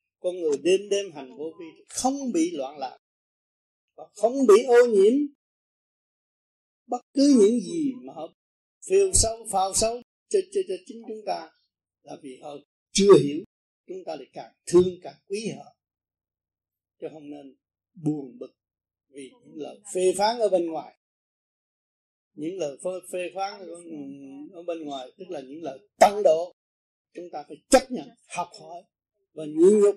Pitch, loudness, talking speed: 200 Hz, -23 LUFS, 160 wpm